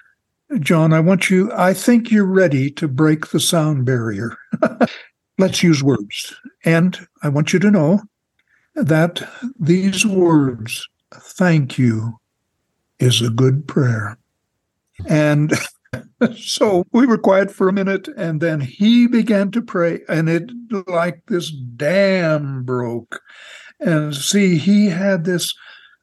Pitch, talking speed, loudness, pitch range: 170 Hz, 130 wpm, -17 LUFS, 140-195 Hz